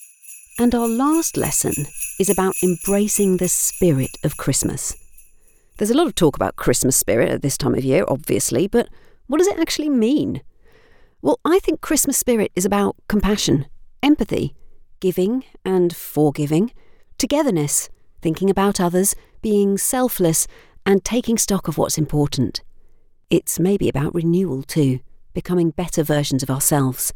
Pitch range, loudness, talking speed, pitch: 160-240 Hz, -19 LUFS, 140 wpm, 190 Hz